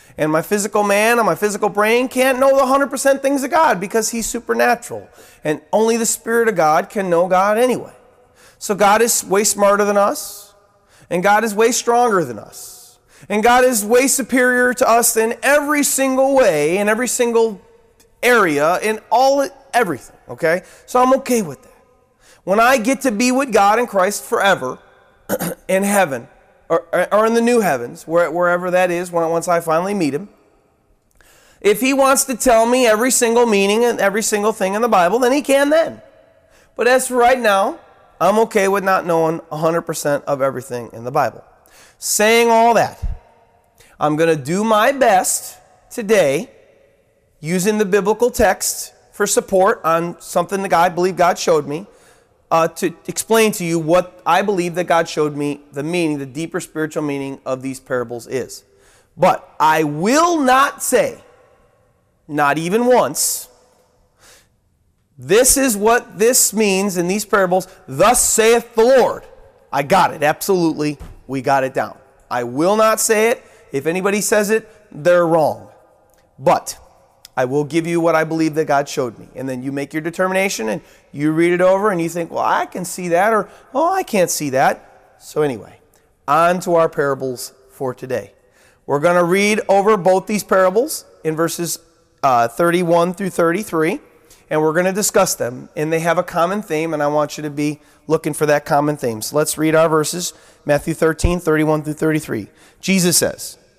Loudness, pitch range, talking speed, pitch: -16 LUFS, 160-230 Hz, 175 wpm, 190 Hz